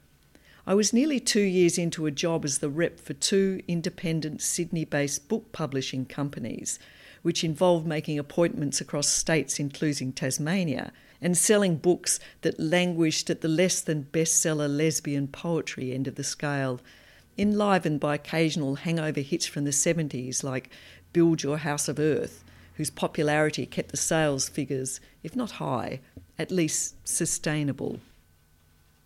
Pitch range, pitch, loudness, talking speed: 140-170 Hz, 155 Hz, -27 LUFS, 140 wpm